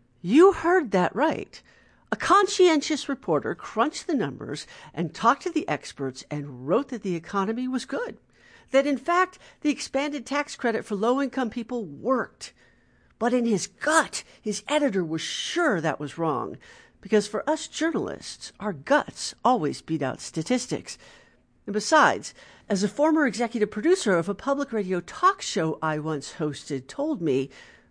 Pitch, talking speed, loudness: 235 Hz, 155 wpm, -25 LUFS